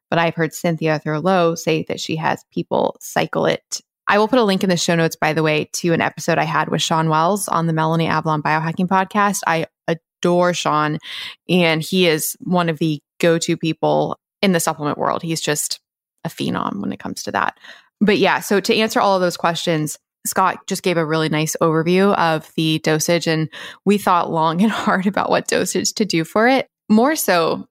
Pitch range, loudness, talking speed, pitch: 160-190 Hz, -18 LUFS, 210 wpm, 165 Hz